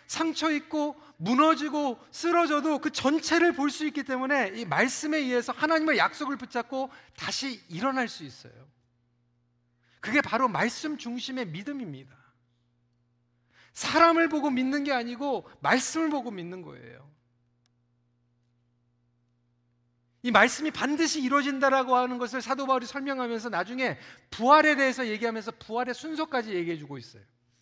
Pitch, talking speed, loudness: 250 Hz, 305 characters per minute, -27 LUFS